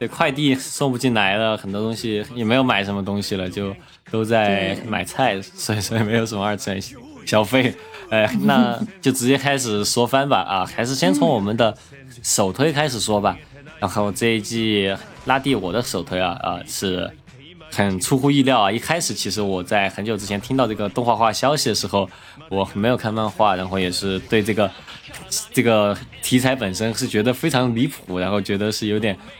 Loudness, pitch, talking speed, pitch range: -20 LUFS, 110 Hz, 280 characters per minute, 100-125 Hz